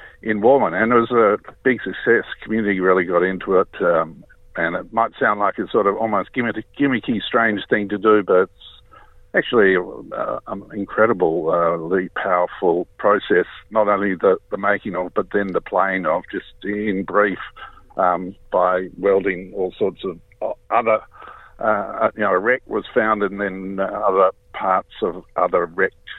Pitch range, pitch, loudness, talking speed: 95-110 Hz, 100 Hz, -19 LUFS, 165 wpm